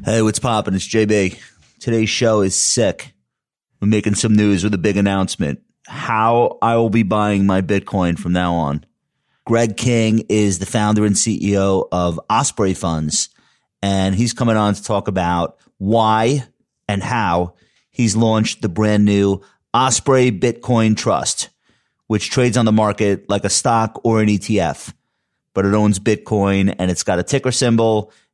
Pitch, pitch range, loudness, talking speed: 105 Hz, 100-115 Hz, -17 LUFS, 160 wpm